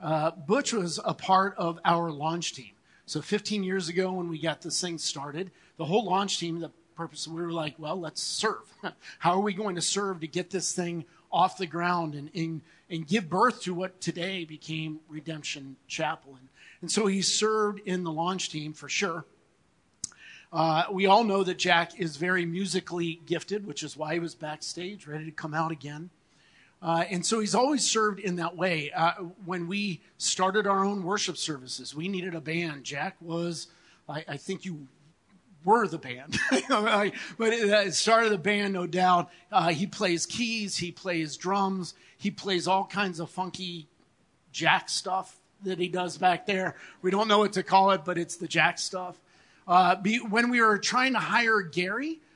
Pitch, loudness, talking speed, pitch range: 180 Hz, -28 LUFS, 190 wpm, 165-195 Hz